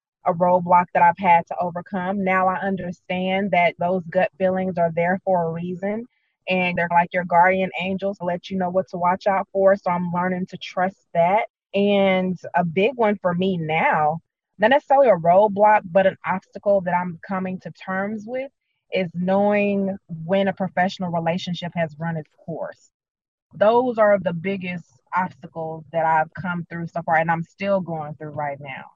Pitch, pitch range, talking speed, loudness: 180 Hz, 170-195 Hz, 180 wpm, -21 LUFS